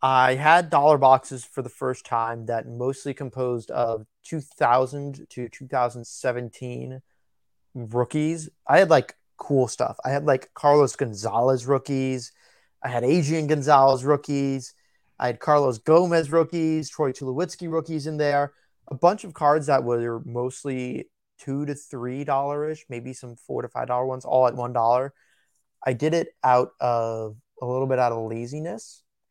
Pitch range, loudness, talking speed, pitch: 120-145 Hz, -23 LUFS, 160 wpm, 130 Hz